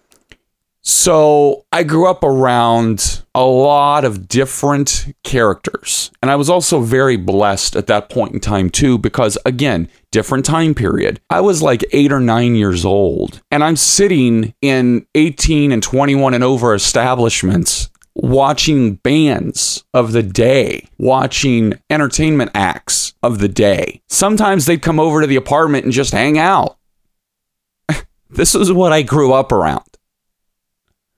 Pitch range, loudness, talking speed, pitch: 115-150 Hz, -13 LUFS, 140 wpm, 135 Hz